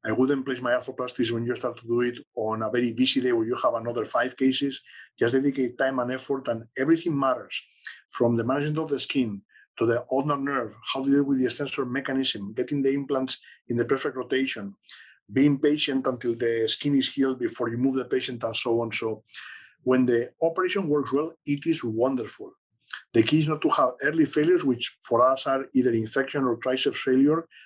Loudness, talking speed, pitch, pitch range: -25 LUFS, 205 wpm, 130 Hz, 120-140 Hz